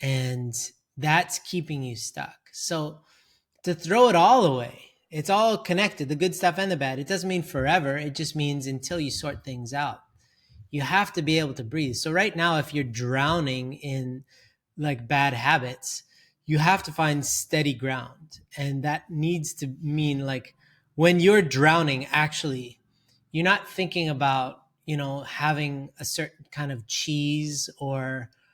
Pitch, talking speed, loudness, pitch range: 150 Hz, 165 wpm, -25 LUFS, 135-160 Hz